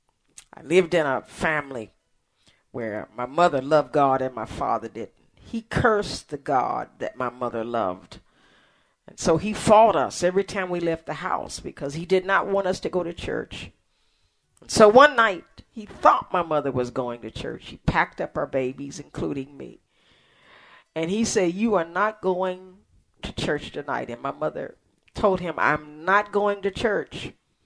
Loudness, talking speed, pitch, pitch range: -23 LUFS, 180 wpm, 180 Hz, 140-200 Hz